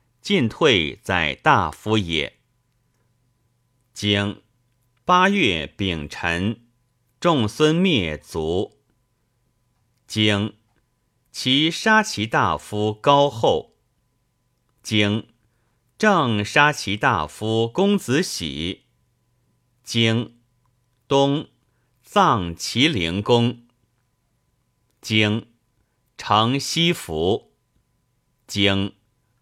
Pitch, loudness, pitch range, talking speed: 120 Hz, -20 LUFS, 110-125 Hz, 90 characters per minute